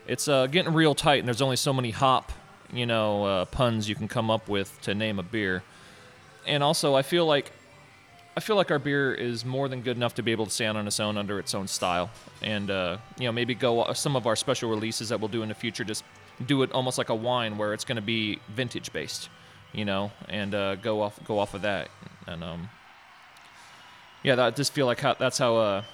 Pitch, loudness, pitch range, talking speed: 115 Hz, -27 LUFS, 105-130 Hz, 240 wpm